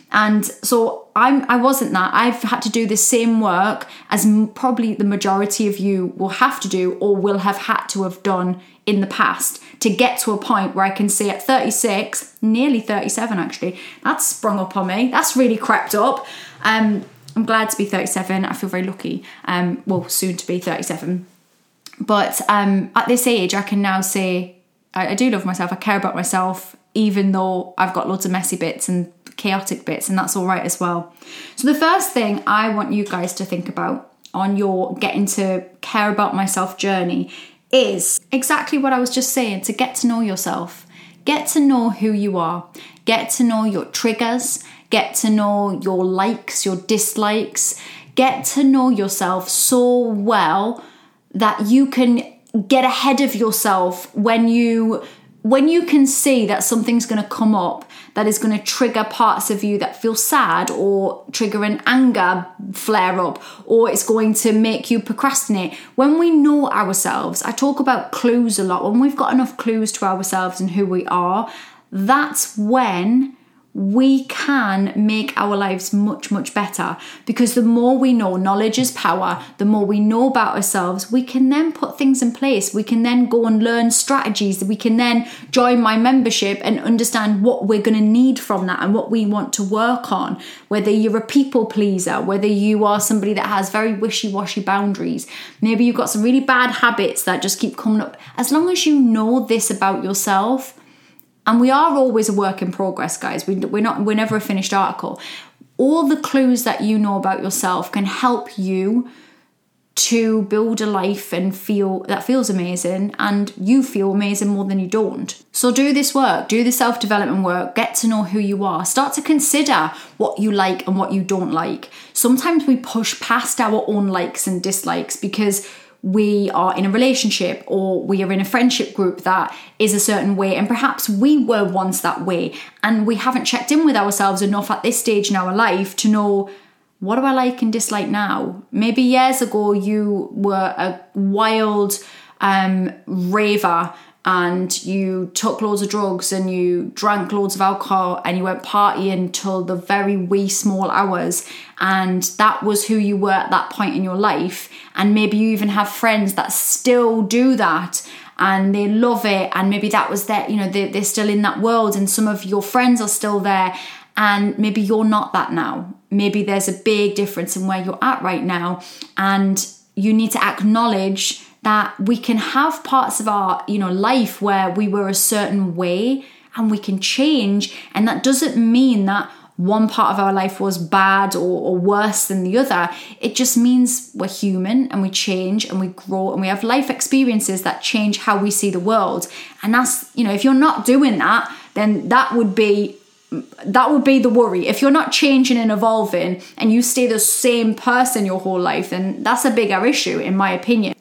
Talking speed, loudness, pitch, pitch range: 195 wpm, -17 LUFS, 210 Hz, 195-245 Hz